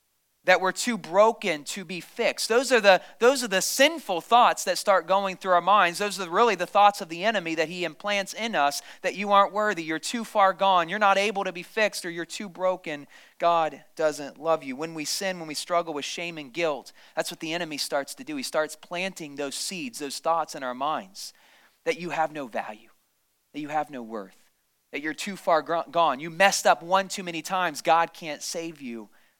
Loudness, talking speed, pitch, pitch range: -25 LUFS, 220 wpm, 175 Hz, 160-200 Hz